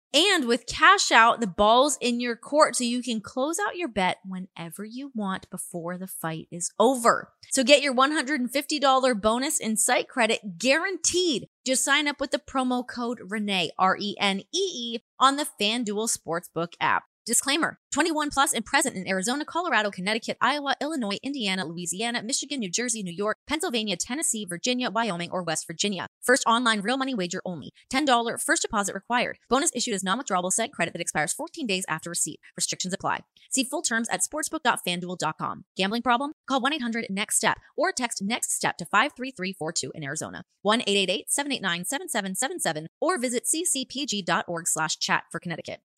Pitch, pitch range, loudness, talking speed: 230 Hz, 185-270 Hz, -25 LUFS, 165 wpm